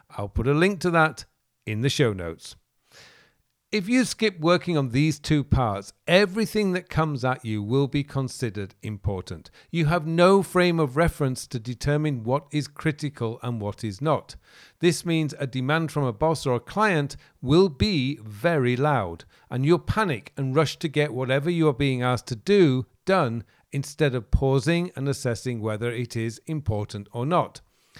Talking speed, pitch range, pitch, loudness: 175 wpm, 120-165 Hz, 140 Hz, -24 LUFS